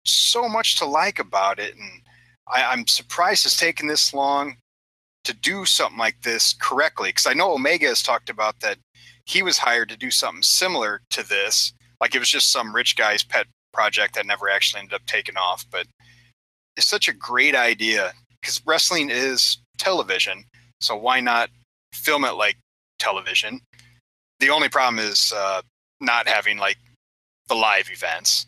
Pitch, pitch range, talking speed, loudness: 120 Hz, 110-140 Hz, 170 wpm, -20 LUFS